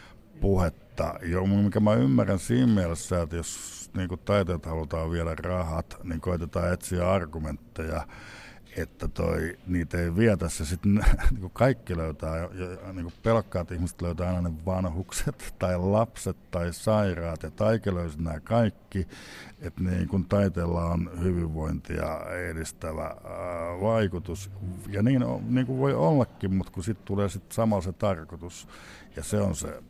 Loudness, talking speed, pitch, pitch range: -28 LUFS, 135 wpm, 90 Hz, 85-100 Hz